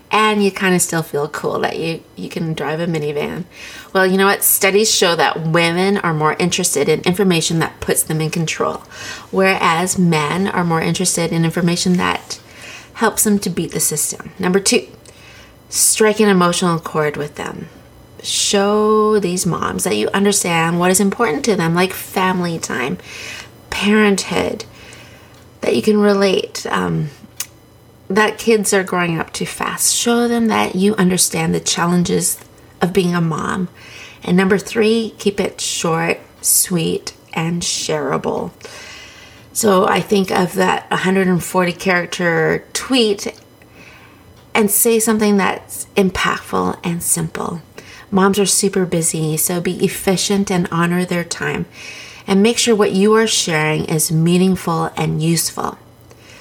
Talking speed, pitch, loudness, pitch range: 145 wpm, 185 Hz, -16 LUFS, 165-205 Hz